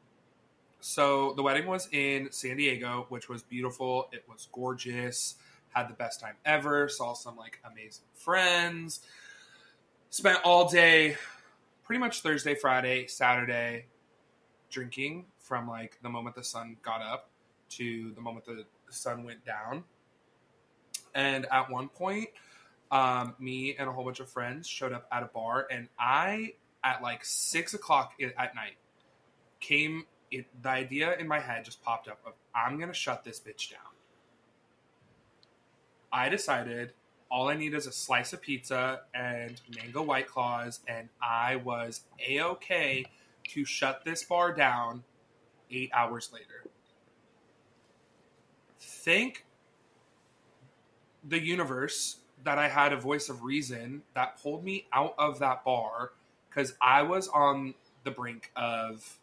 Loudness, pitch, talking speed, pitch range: -30 LUFS, 130 Hz, 140 wpm, 120-150 Hz